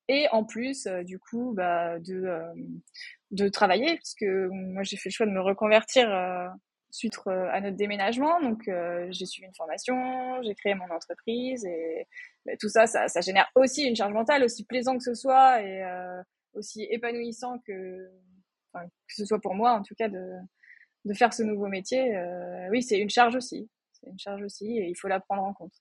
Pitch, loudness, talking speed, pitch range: 205 Hz, -27 LUFS, 200 wpm, 185-245 Hz